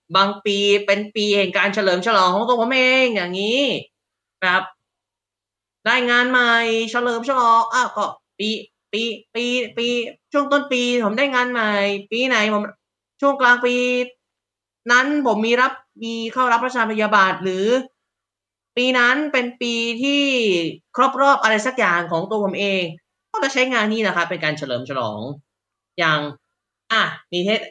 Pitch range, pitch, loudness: 195-250 Hz, 225 Hz, -18 LUFS